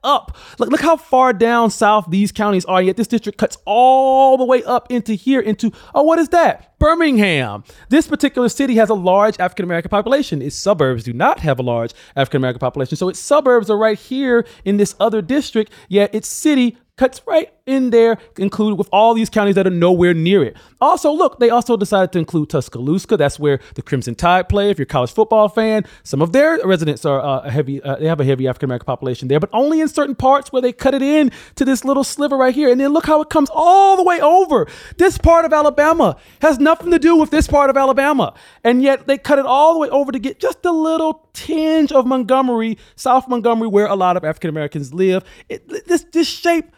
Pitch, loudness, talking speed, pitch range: 235 Hz, -15 LUFS, 230 wpm, 185-290 Hz